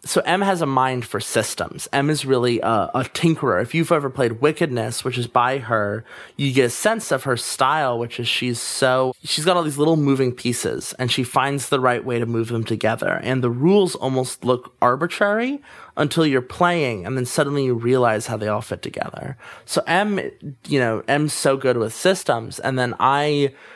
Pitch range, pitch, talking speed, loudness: 120-150 Hz, 130 Hz, 205 wpm, -20 LUFS